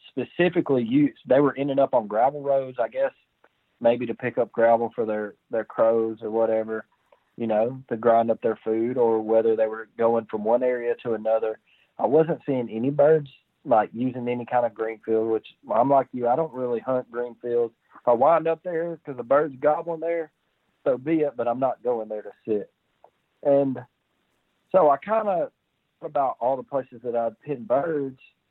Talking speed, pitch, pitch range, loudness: 190 wpm, 125 Hz, 115-145 Hz, -24 LUFS